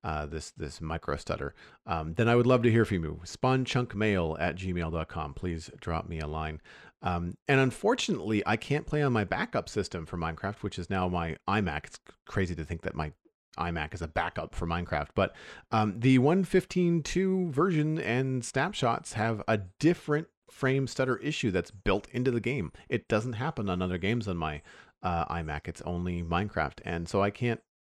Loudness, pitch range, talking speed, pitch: -30 LUFS, 85-125 Hz, 185 wpm, 100 Hz